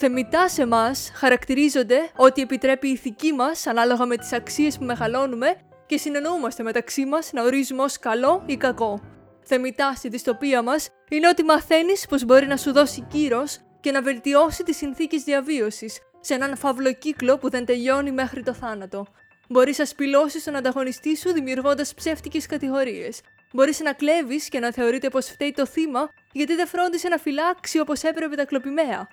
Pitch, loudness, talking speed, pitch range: 275 Hz, -22 LUFS, 170 wpm, 255-305 Hz